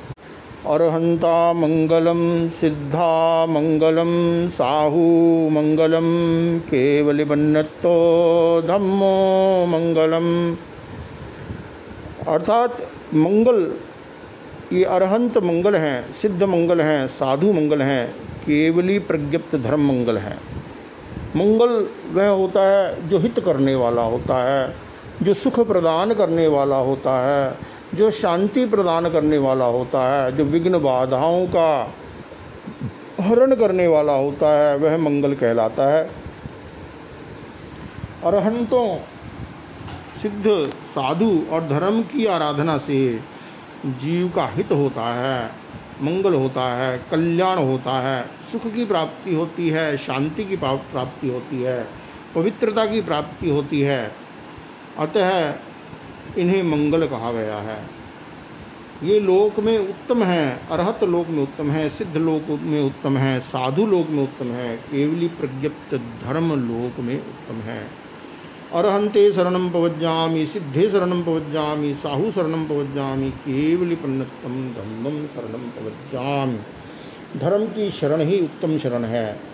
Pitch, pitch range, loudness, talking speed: 155 Hz, 135-180 Hz, -20 LUFS, 115 wpm